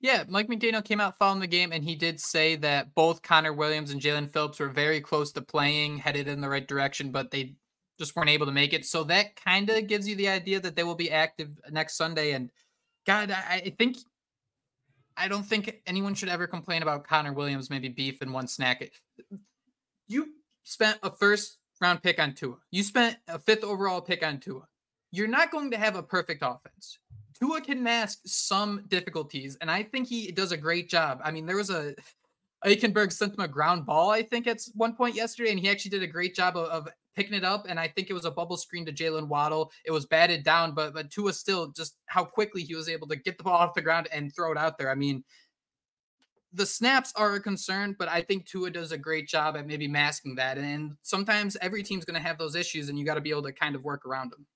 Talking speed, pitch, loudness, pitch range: 235 wpm, 170 Hz, -28 LUFS, 150-200 Hz